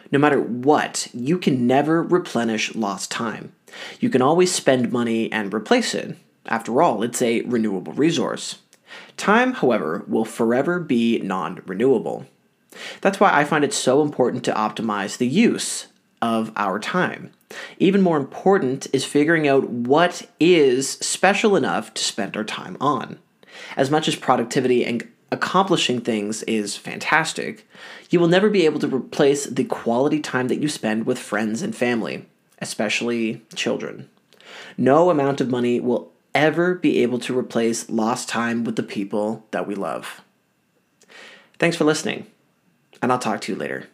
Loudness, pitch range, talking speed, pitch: -21 LUFS, 115-160 Hz, 155 wpm, 125 Hz